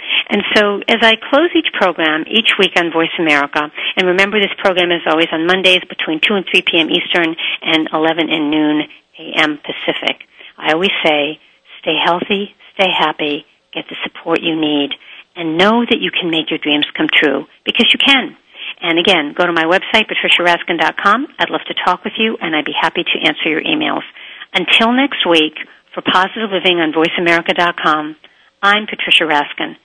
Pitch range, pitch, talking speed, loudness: 160-200 Hz, 175 Hz, 180 wpm, -13 LUFS